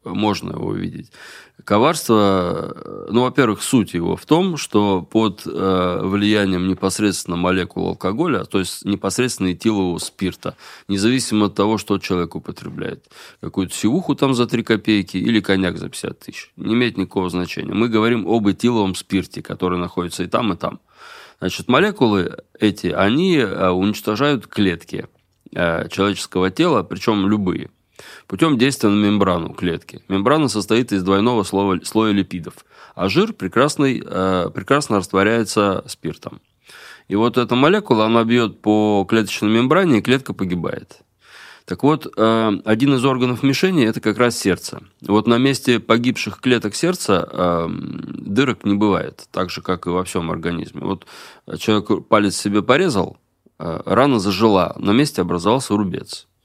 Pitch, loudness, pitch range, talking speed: 105 Hz, -18 LUFS, 95-120 Hz, 135 wpm